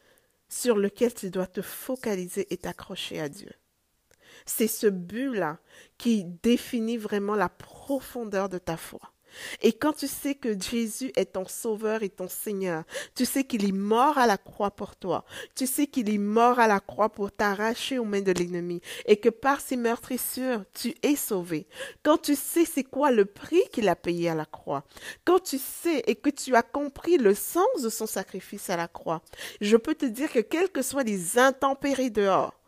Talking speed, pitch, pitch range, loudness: 195 wpm, 230 Hz, 195-270 Hz, -27 LUFS